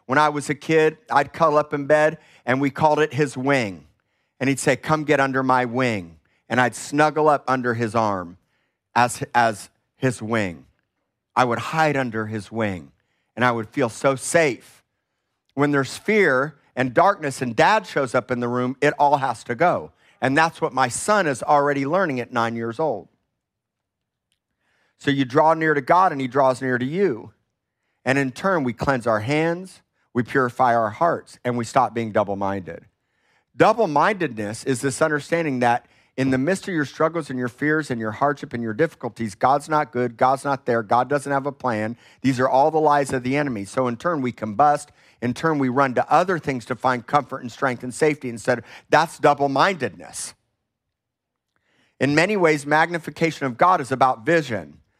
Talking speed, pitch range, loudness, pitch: 195 wpm, 120-150 Hz, -21 LUFS, 135 Hz